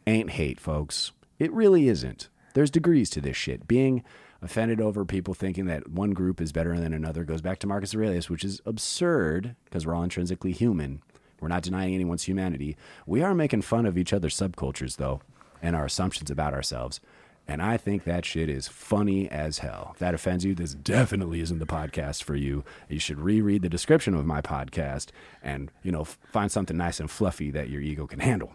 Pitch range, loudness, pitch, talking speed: 75-100 Hz, -28 LUFS, 90 Hz, 205 wpm